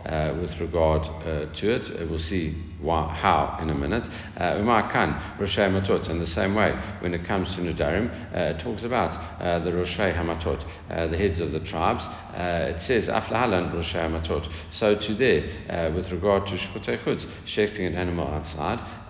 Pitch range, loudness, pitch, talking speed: 80-95 Hz, -26 LUFS, 85 Hz, 190 wpm